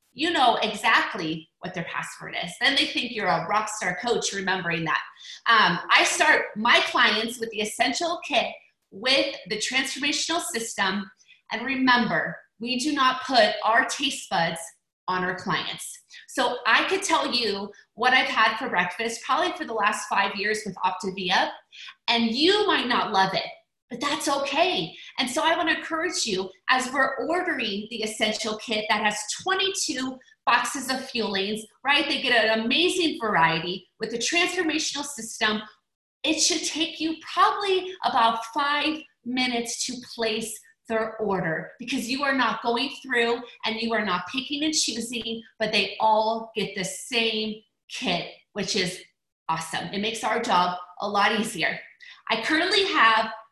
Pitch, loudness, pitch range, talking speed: 235 Hz, -24 LUFS, 210-290 Hz, 160 wpm